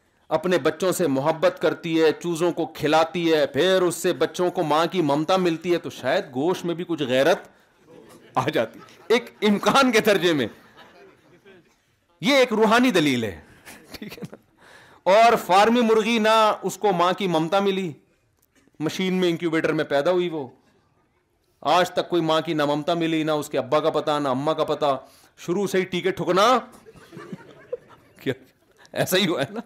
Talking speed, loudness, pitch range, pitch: 180 wpm, -22 LUFS, 160-195 Hz, 175 Hz